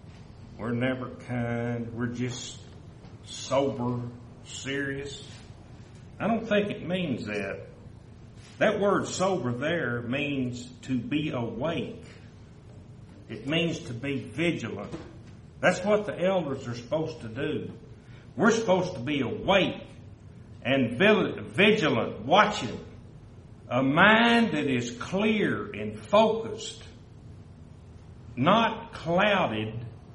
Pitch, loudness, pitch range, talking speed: 125 Hz, -27 LUFS, 115-155 Hz, 100 wpm